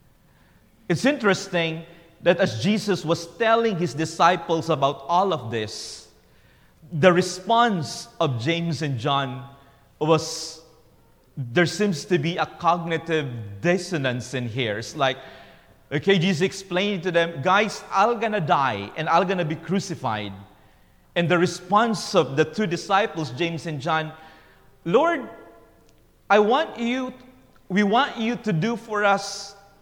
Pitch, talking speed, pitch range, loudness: 170 Hz, 135 wpm, 150-195 Hz, -23 LUFS